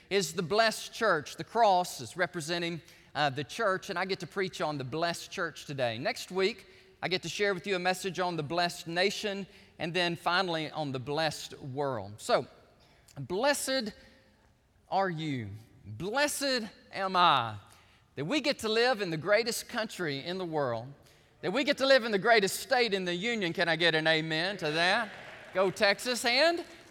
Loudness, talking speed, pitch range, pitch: -30 LUFS, 185 wpm, 155-210 Hz, 180 Hz